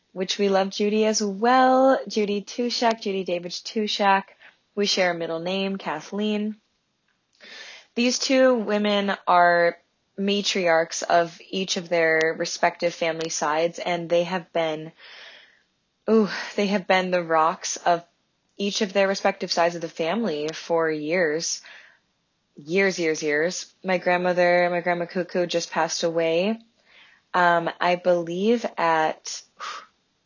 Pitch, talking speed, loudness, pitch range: 180 Hz, 130 wpm, -23 LUFS, 170-205 Hz